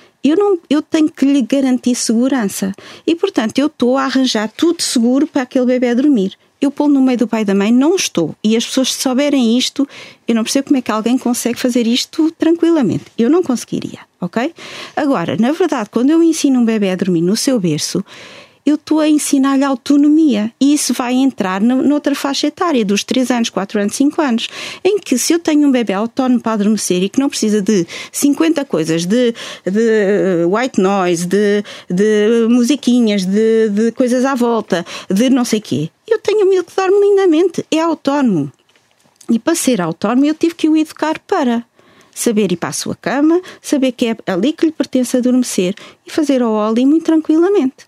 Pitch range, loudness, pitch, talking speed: 220-295 Hz, -14 LUFS, 255 Hz, 200 wpm